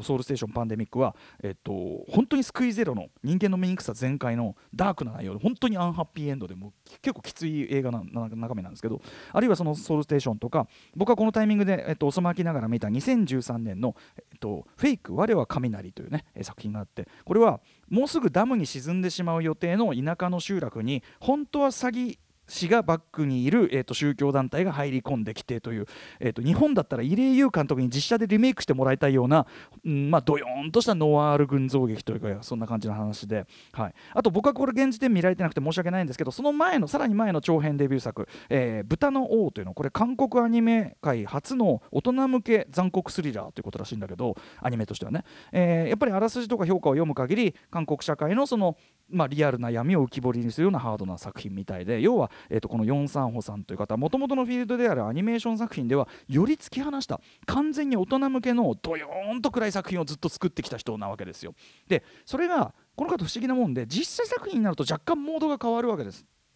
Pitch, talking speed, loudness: 165 Hz, 465 characters per minute, -26 LUFS